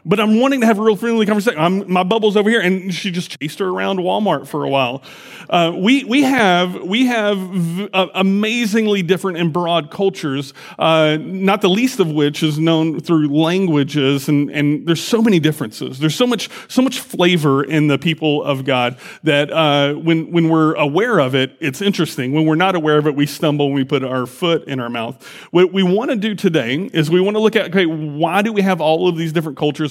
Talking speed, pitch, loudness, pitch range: 225 wpm, 170 Hz, -16 LUFS, 150-200 Hz